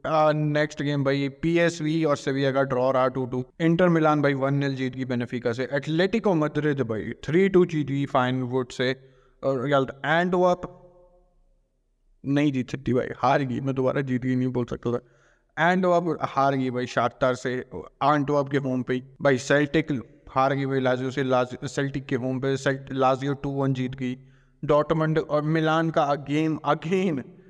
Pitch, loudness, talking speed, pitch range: 140 Hz, -24 LUFS, 110 wpm, 130-155 Hz